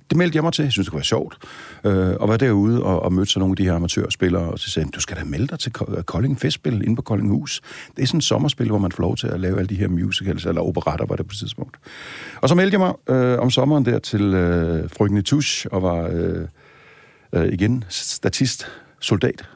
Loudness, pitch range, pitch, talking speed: -20 LUFS, 90-125 Hz, 100 Hz, 250 wpm